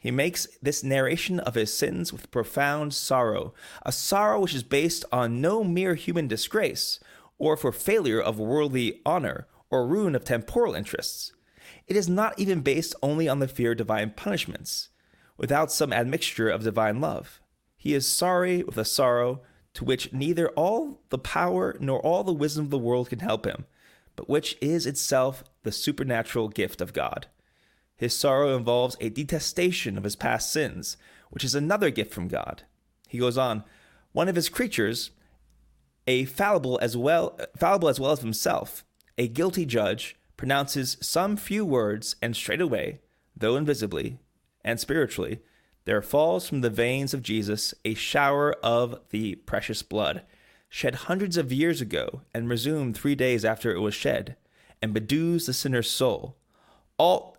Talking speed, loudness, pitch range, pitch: 165 wpm, -26 LUFS, 115-155 Hz, 130 Hz